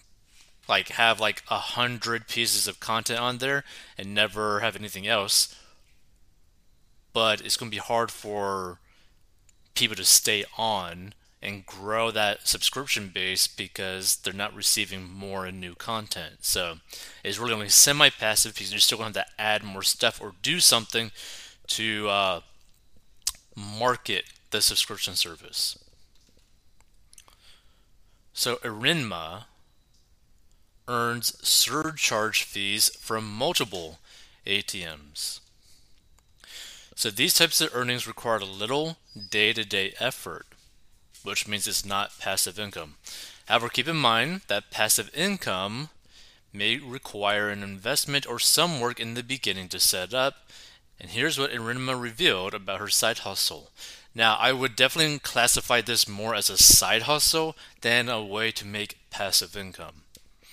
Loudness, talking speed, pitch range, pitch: -24 LUFS, 135 wpm, 95-120 Hz, 105 Hz